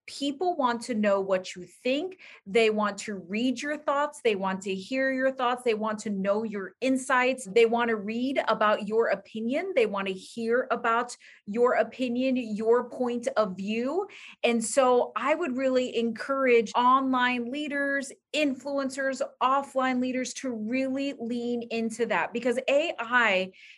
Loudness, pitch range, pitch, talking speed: -27 LUFS, 220-265 Hz, 245 Hz, 155 wpm